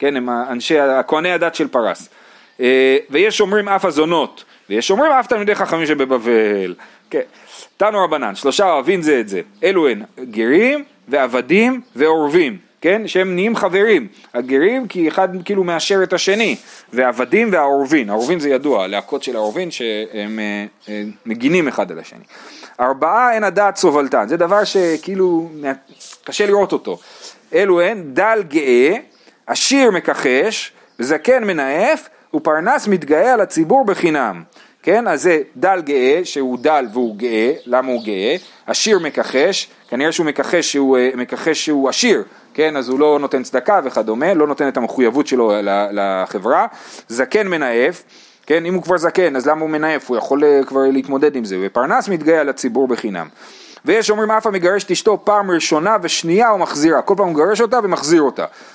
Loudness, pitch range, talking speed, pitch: -16 LUFS, 130-205 Hz, 155 wpm, 160 Hz